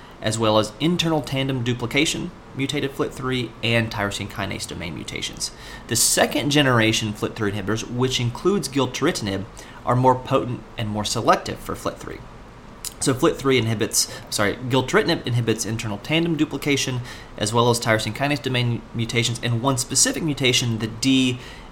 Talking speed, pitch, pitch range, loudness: 140 wpm, 120 Hz, 110-135 Hz, -22 LUFS